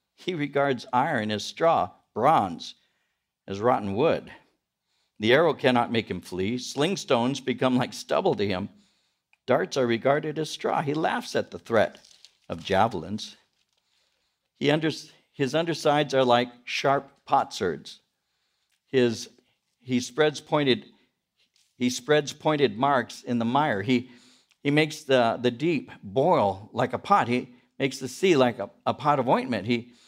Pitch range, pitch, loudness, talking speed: 120-145 Hz, 130 Hz, -25 LUFS, 145 wpm